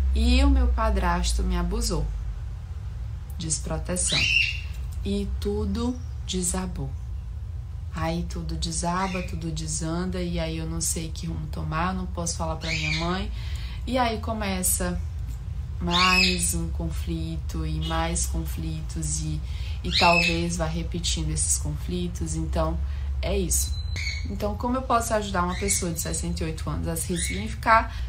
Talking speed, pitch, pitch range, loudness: 130 wpm, 80 Hz, 80-90 Hz, -26 LUFS